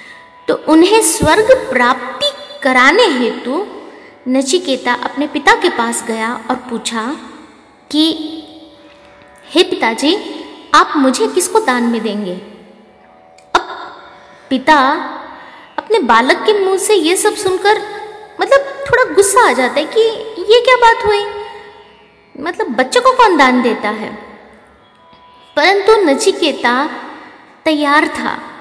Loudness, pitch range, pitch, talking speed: -12 LUFS, 250-415 Hz, 300 Hz, 120 wpm